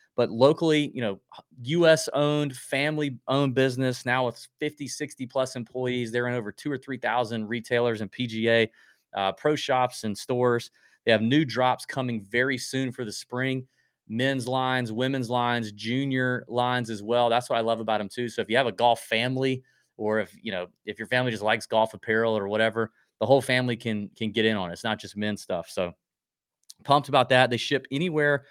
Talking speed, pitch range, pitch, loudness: 200 wpm, 115-130 Hz, 125 Hz, -26 LUFS